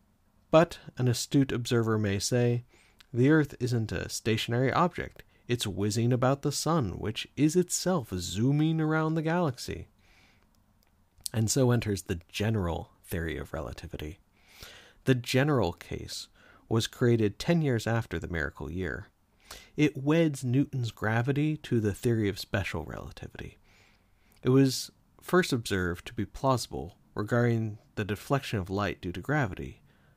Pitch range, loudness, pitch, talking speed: 95-135 Hz, -29 LUFS, 110 Hz, 135 wpm